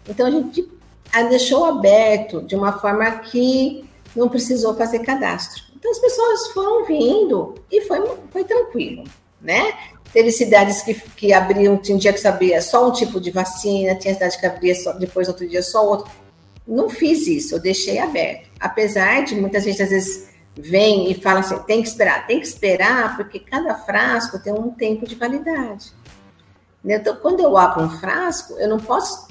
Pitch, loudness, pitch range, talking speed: 220 Hz, -18 LUFS, 190-275 Hz, 180 wpm